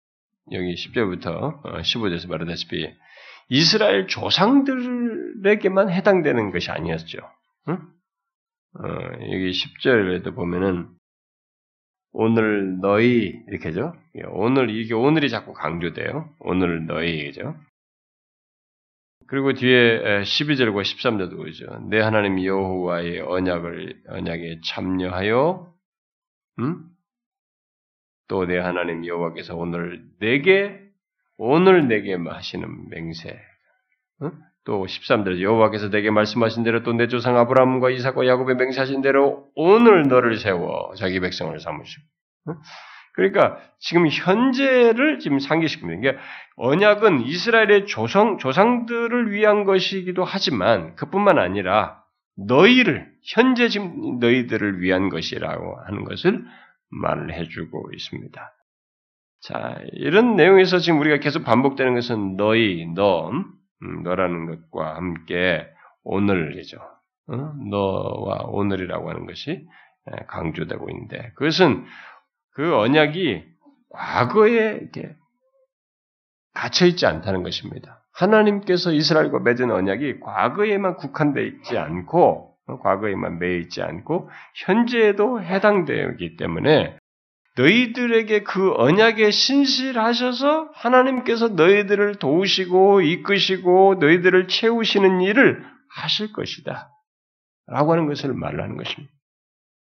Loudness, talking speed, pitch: -20 LUFS, 265 characters per minute, 150 Hz